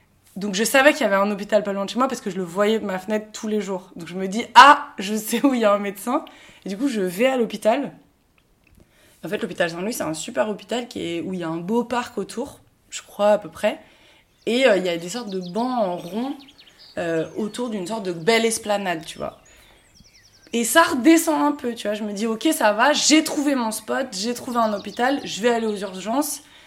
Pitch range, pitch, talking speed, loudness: 200-250 Hz, 220 Hz, 255 wpm, -21 LUFS